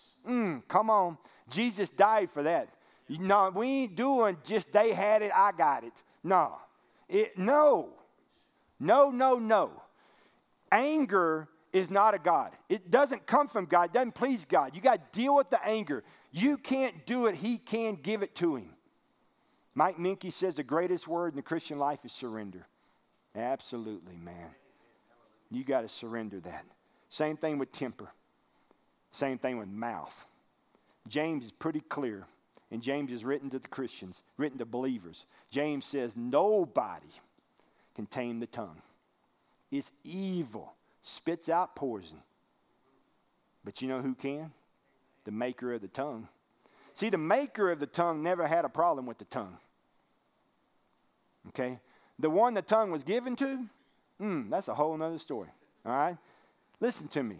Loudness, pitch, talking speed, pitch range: -31 LUFS, 165 Hz, 155 wpm, 130-220 Hz